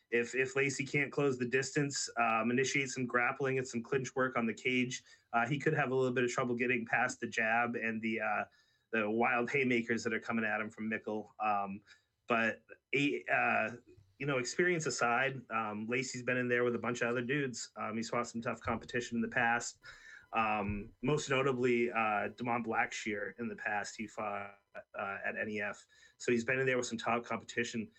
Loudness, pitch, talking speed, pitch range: -34 LUFS, 120 Hz, 205 wpm, 115-130 Hz